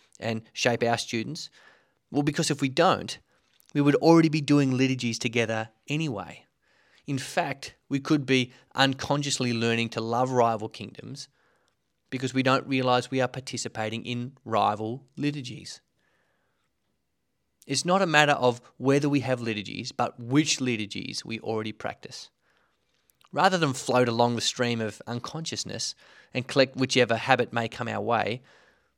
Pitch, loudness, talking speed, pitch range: 125 Hz, -26 LUFS, 145 wpm, 115-140 Hz